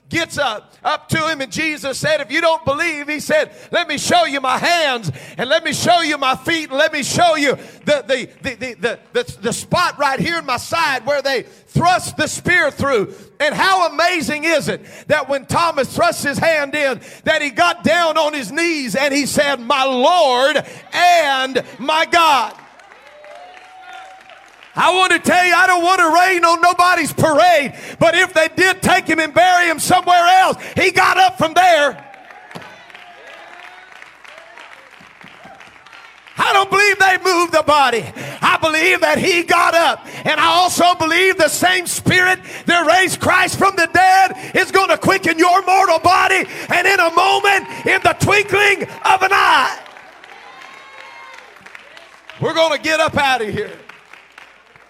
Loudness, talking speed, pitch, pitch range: -14 LUFS, 175 wpm, 335 Hz, 295-365 Hz